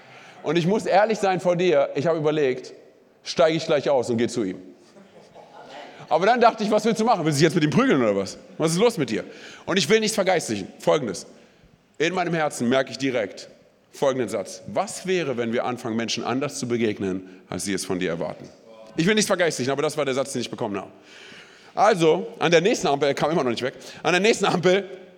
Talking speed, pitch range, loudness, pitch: 230 wpm, 120-185 Hz, -22 LUFS, 145 Hz